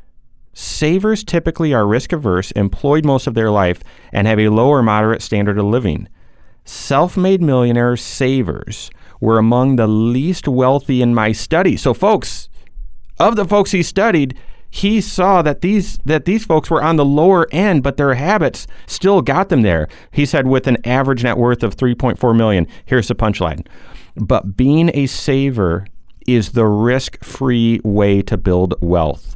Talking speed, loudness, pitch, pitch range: 160 wpm, -15 LUFS, 125 Hz, 105-150 Hz